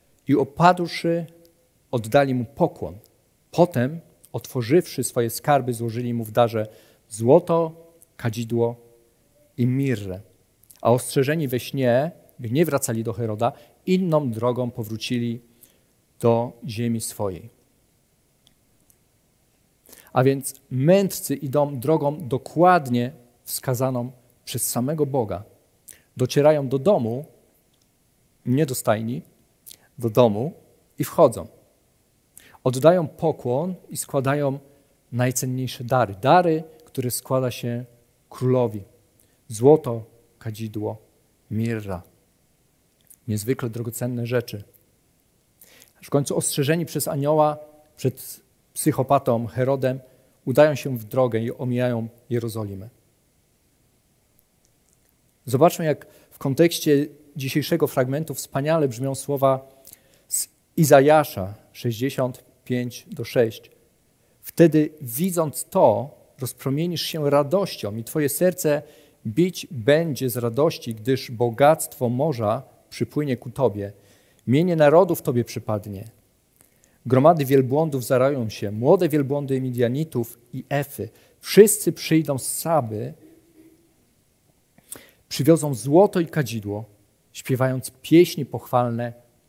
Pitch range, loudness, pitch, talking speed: 120-150 Hz, -22 LUFS, 130 Hz, 90 wpm